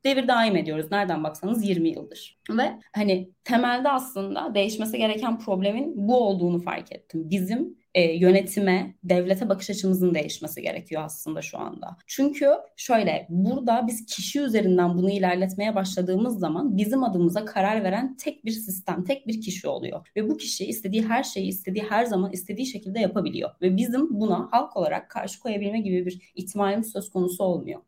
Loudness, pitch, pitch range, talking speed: -25 LUFS, 200 Hz, 185-230 Hz, 160 wpm